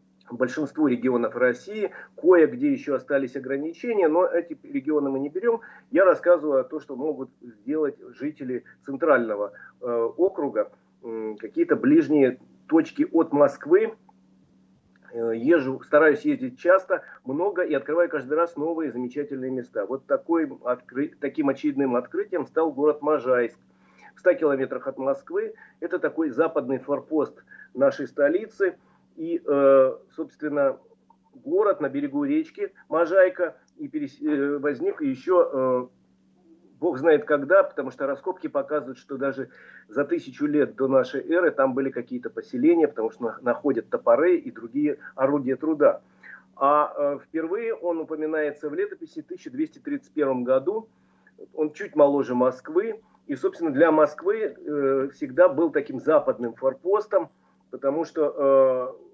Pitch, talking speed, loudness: 155 Hz, 135 wpm, -24 LUFS